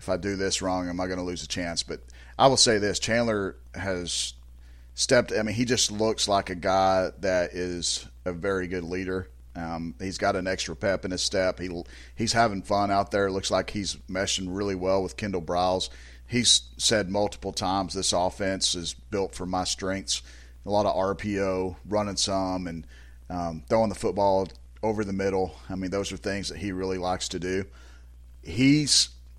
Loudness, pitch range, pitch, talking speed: -26 LUFS, 85-100 Hz, 95 Hz, 195 wpm